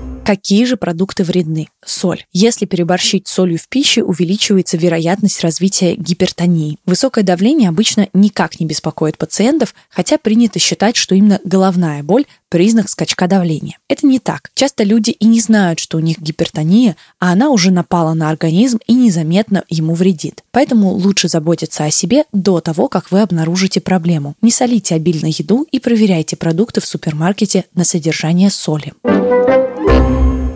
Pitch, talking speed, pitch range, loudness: 185 Hz, 150 wpm, 170-215 Hz, -13 LUFS